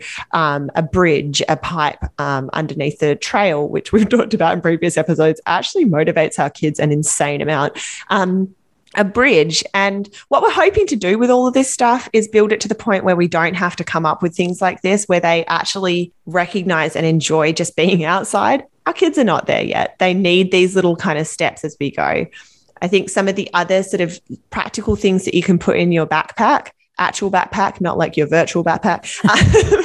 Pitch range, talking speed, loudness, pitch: 160-200 Hz, 205 wpm, -16 LUFS, 180 Hz